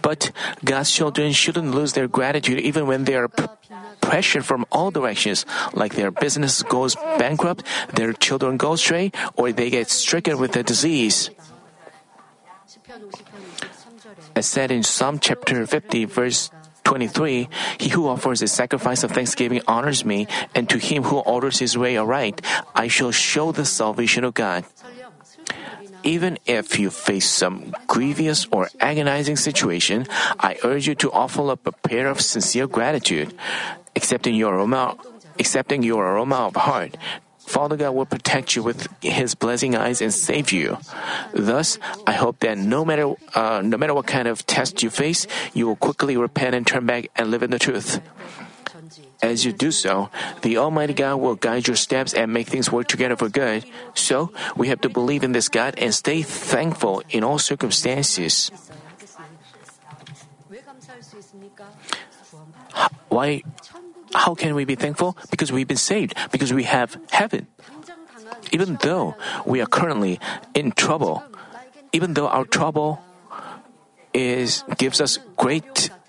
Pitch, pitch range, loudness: 145 Hz, 125-160 Hz, -21 LUFS